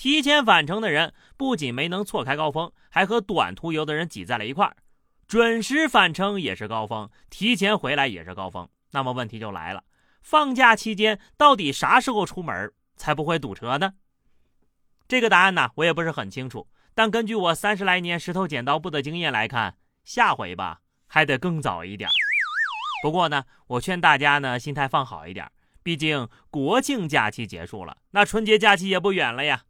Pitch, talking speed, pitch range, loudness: 170 Hz, 280 characters per minute, 140-210 Hz, -22 LUFS